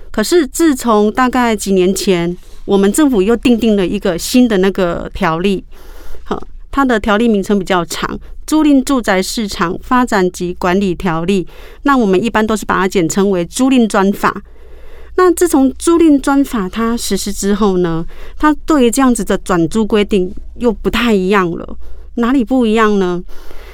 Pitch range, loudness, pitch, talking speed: 190-265 Hz, -13 LUFS, 215 Hz, 255 characters per minute